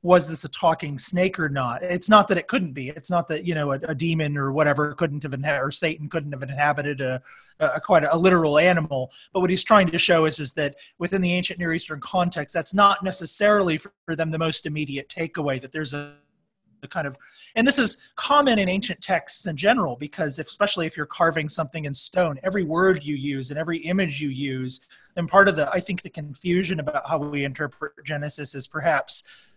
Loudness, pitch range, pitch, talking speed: -23 LUFS, 145-180 Hz, 160 Hz, 225 wpm